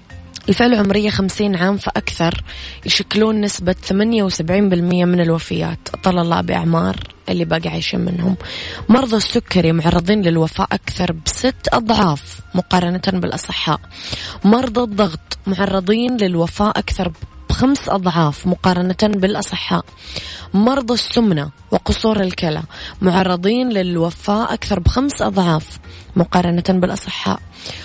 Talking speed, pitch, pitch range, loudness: 105 wpm, 185 Hz, 165-205 Hz, -17 LUFS